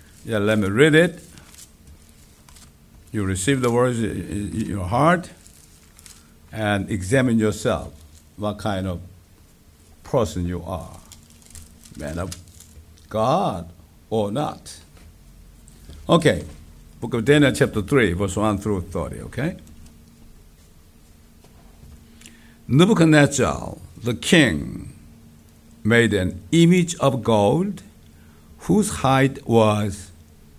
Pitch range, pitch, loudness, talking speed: 75-110 Hz, 90 Hz, -20 LUFS, 90 wpm